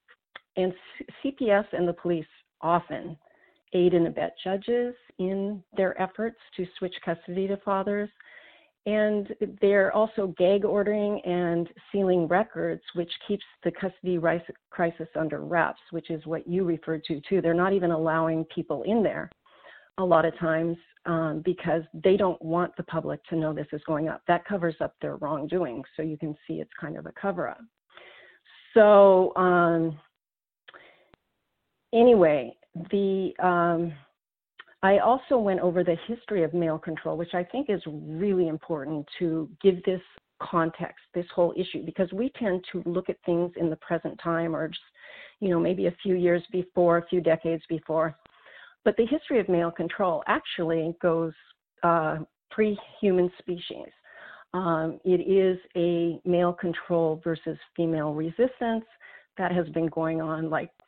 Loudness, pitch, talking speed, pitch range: -27 LUFS, 175 Hz, 155 wpm, 165-195 Hz